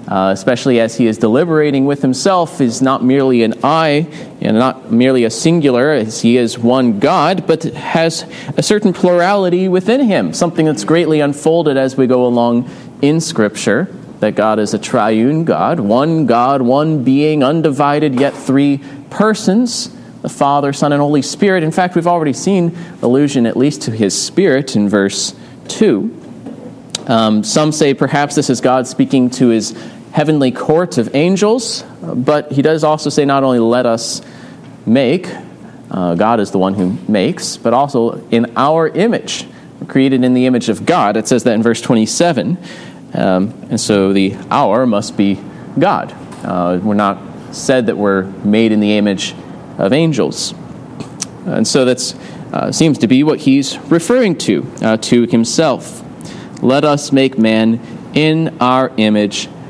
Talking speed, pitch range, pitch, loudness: 165 wpm, 115-155 Hz, 135 Hz, -13 LUFS